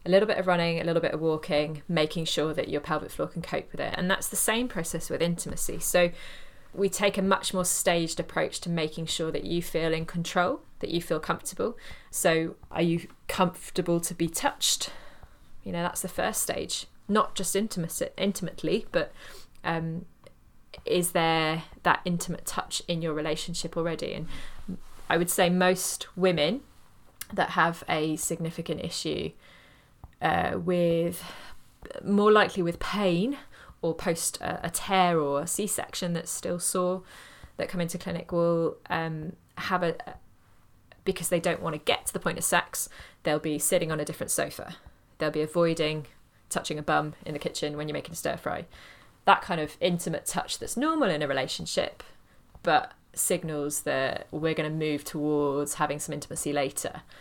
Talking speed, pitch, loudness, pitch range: 175 wpm, 170 Hz, -28 LUFS, 155-180 Hz